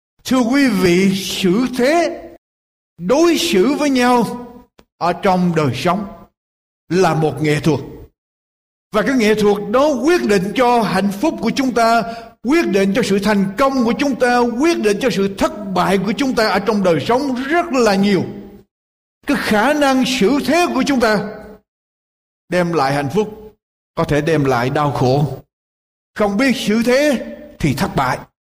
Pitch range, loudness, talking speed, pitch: 180-255 Hz, -16 LUFS, 170 wpm, 215 Hz